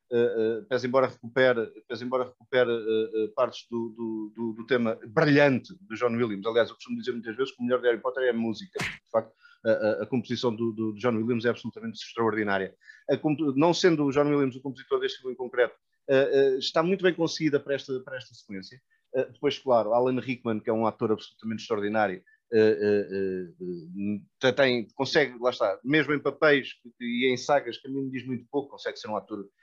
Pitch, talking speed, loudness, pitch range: 125 Hz, 215 wpm, -27 LUFS, 115-145 Hz